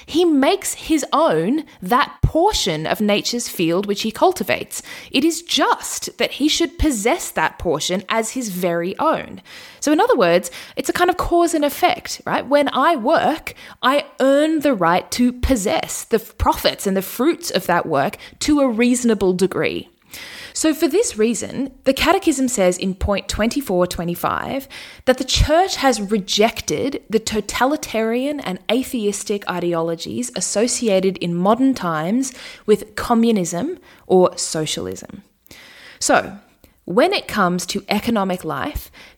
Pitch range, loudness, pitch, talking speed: 195-295 Hz, -19 LUFS, 240 Hz, 140 wpm